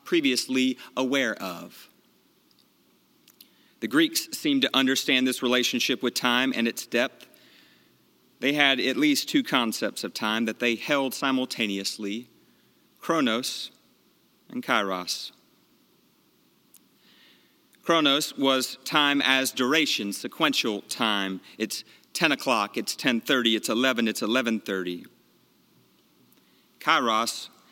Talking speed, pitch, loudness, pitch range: 100 wpm, 130 Hz, -25 LUFS, 115-135 Hz